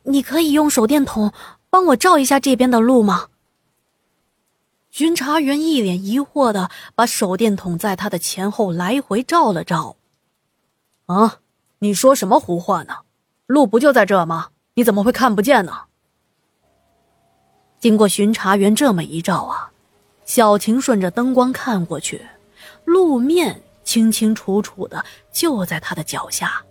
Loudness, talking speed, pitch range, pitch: -17 LUFS, 210 characters per minute, 195-275 Hz, 225 Hz